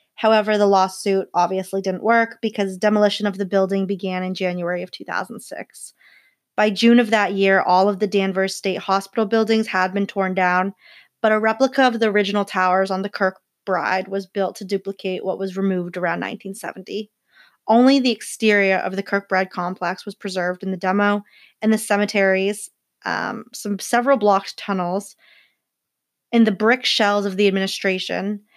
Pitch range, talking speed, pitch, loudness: 190-210 Hz, 165 wpm, 195 Hz, -20 LUFS